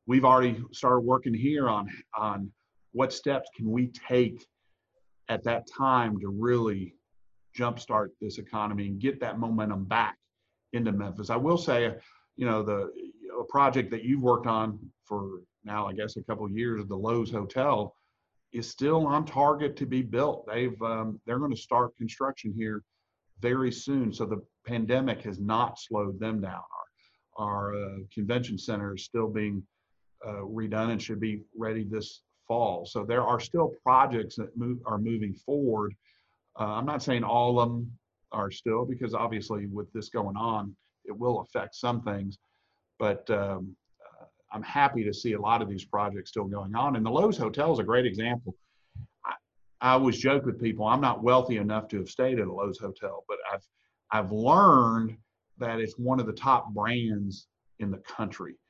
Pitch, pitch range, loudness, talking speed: 110 Hz, 105-120 Hz, -29 LUFS, 180 wpm